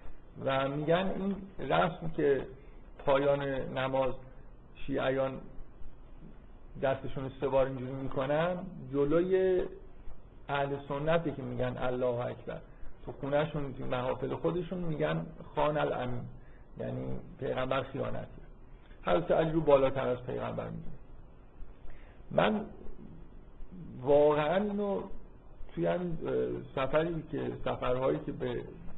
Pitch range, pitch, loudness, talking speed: 130-160 Hz, 140 Hz, -32 LUFS, 95 wpm